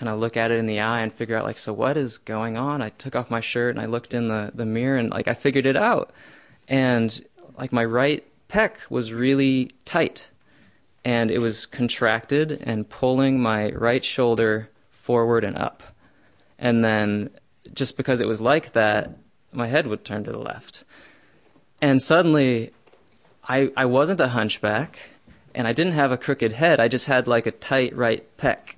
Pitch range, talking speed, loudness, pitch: 115-135 Hz, 190 wpm, -22 LUFS, 120 Hz